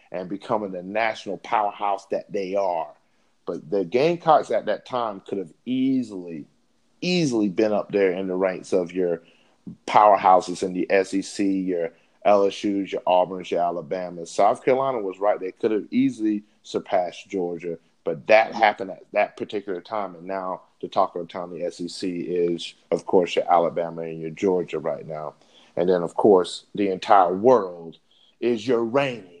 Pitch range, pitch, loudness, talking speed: 85-110 Hz, 95 Hz, -23 LUFS, 165 wpm